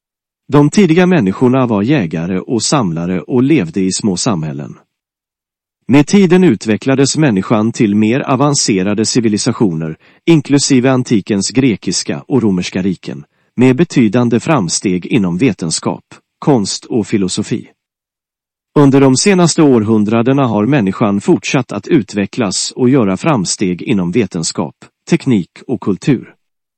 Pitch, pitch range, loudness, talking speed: 125 Hz, 100-140 Hz, -12 LUFS, 115 wpm